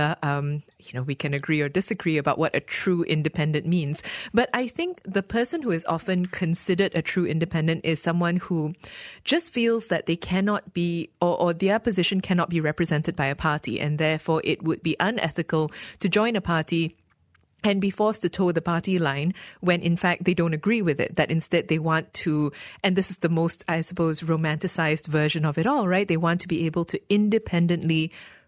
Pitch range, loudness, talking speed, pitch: 160-185 Hz, -24 LUFS, 200 wpm, 170 Hz